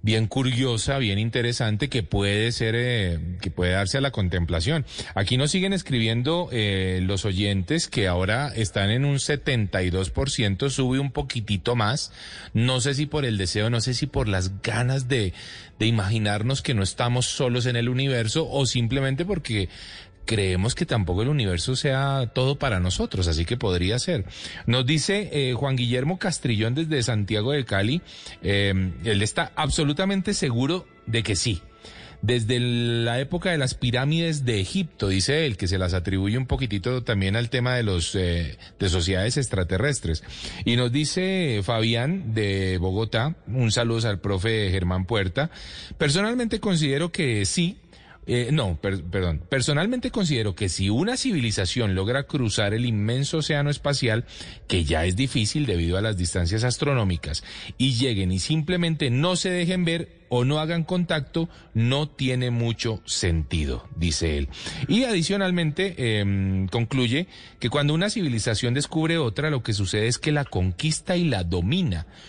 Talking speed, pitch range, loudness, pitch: 160 wpm, 100-145 Hz, -24 LUFS, 120 Hz